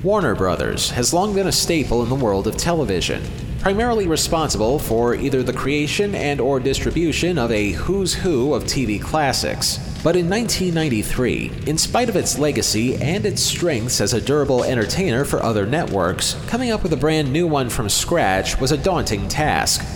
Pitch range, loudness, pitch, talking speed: 120-175 Hz, -19 LUFS, 145 Hz, 175 wpm